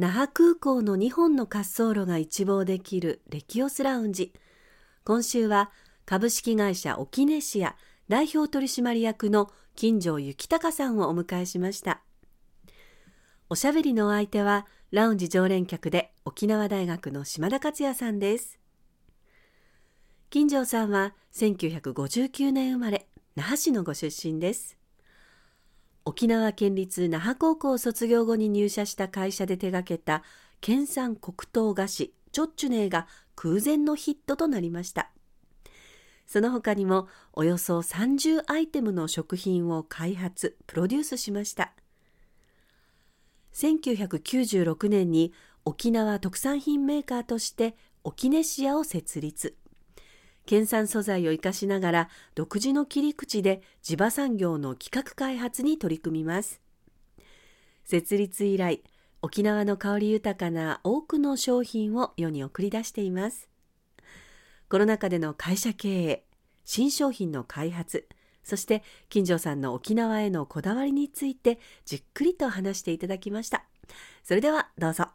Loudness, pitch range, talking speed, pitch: -27 LUFS, 180-255 Hz, 260 characters per minute, 210 Hz